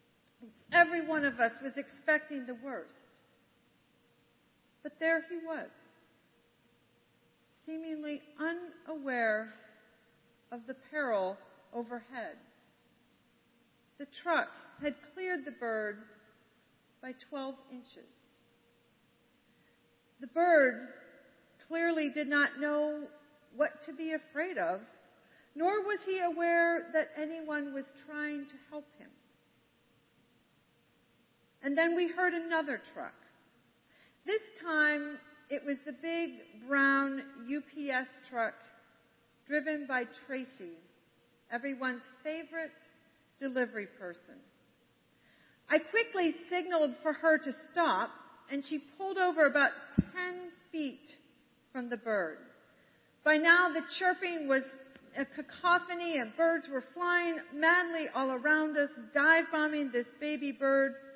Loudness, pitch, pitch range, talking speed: -33 LUFS, 295 Hz, 260-325 Hz, 105 wpm